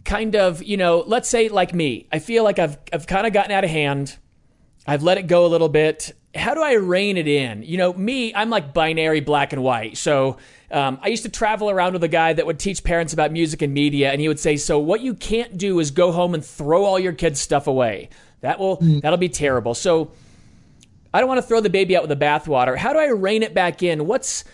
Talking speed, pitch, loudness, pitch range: 250 wpm, 170 Hz, -19 LUFS, 150-195 Hz